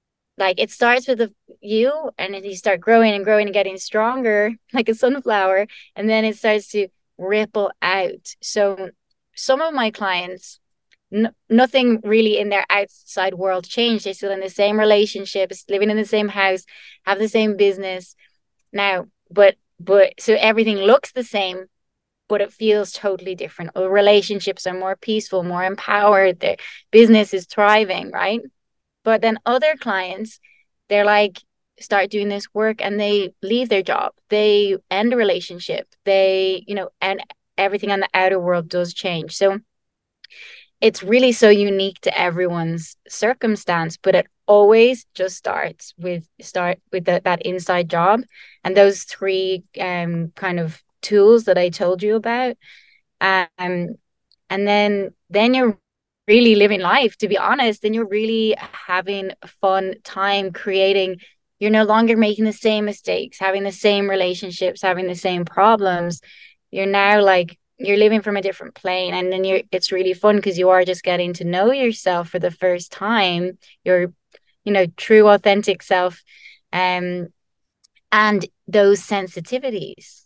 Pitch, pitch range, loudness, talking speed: 200 Hz, 185-215 Hz, -18 LUFS, 160 wpm